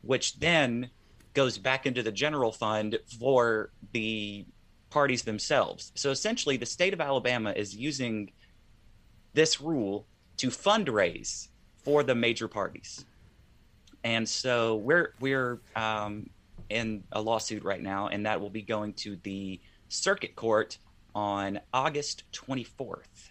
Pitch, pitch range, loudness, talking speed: 110 Hz, 105-130 Hz, -30 LUFS, 130 wpm